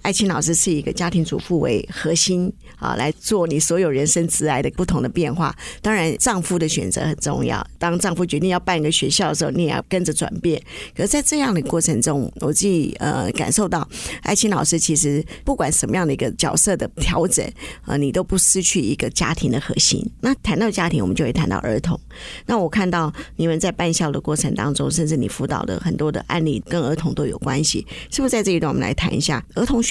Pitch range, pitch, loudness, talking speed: 155-185 Hz, 170 Hz, -19 LUFS, 345 characters per minute